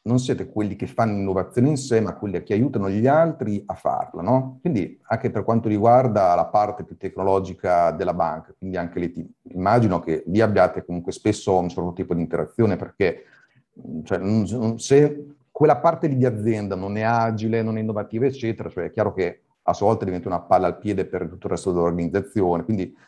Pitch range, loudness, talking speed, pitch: 95-120 Hz, -22 LUFS, 195 wpm, 105 Hz